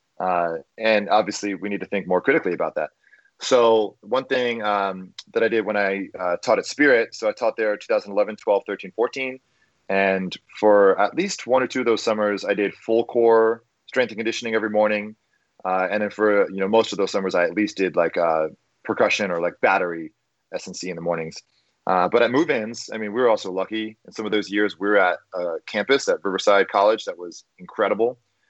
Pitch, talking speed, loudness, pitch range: 105 Hz, 215 wpm, -22 LUFS, 100-120 Hz